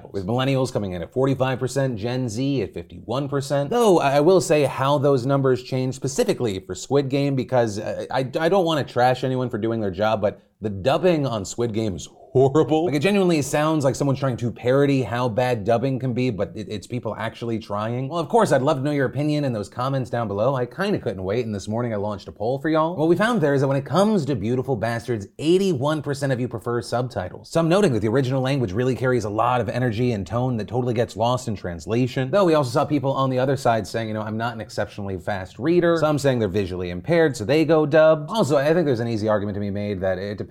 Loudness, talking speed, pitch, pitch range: -22 LUFS, 250 wpm, 125 Hz, 110-145 Hz